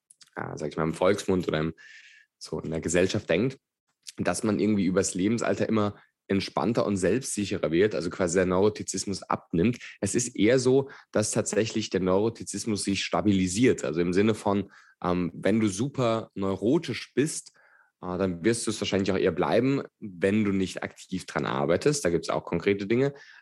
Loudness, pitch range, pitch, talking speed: -27 LUFS, 90-110 Hz, 100 Hz, 175 wpm